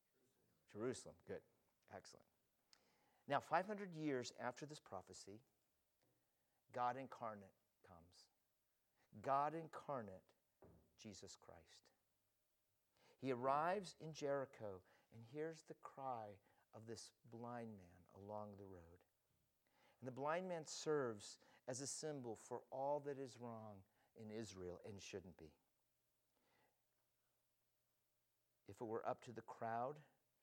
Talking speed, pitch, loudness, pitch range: 110 wpm, 120 Hz, -49 LUFS, 105-145 Hz